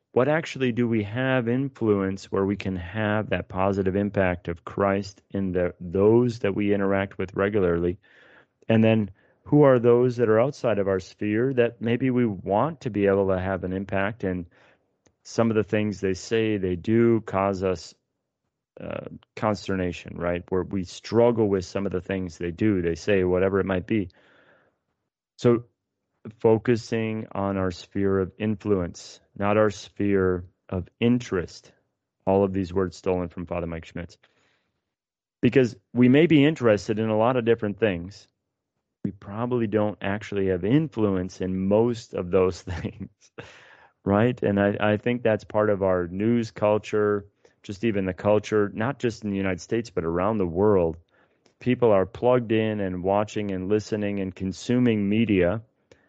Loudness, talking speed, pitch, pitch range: -24 LUFS, 165 wpm, 100 Hz, 95-115 Hz